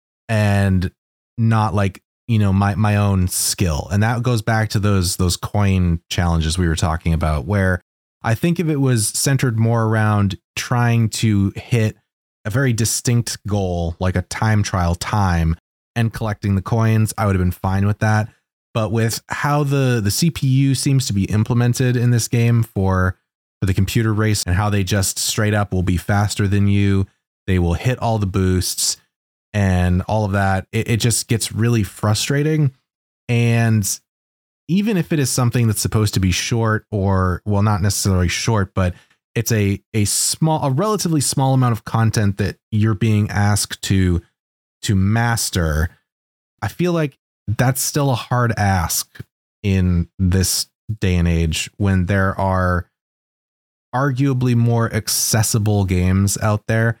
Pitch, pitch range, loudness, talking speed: 105 Hz, 95-115 Hz, -18 LUFS, 165 wpm